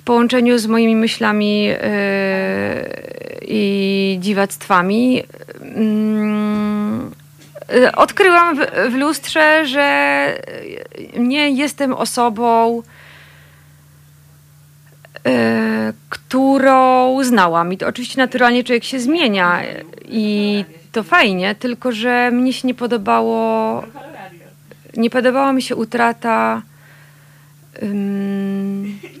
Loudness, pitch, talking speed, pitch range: -15 LUFS, 225 Hz, 85 wpm, 185-255 Hz